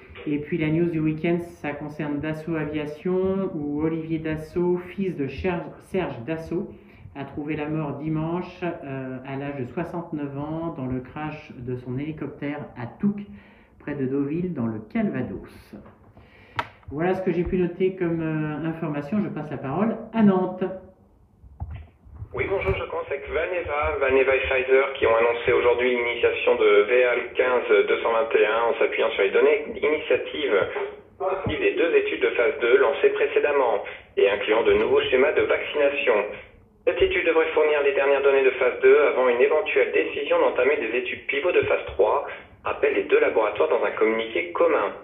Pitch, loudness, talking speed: 180 Hz, -23 LUFS, 165 wpm